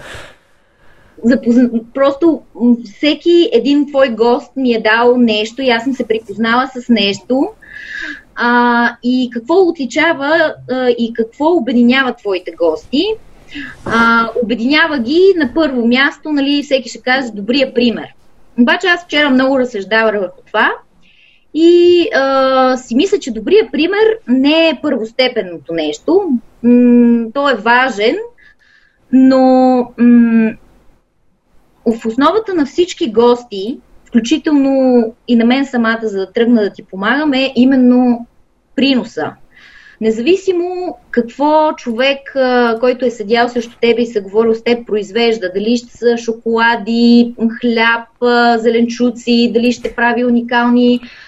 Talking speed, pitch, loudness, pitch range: 125 wpm, 245 Hz, -12 LUFS, 235-280 Hz